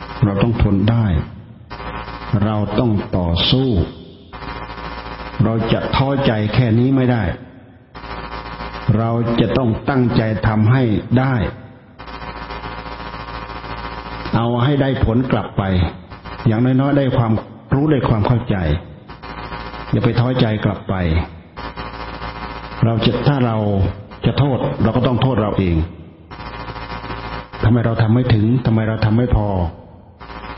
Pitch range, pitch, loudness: 105-120 Hz, 115 Hz, -18 LUFS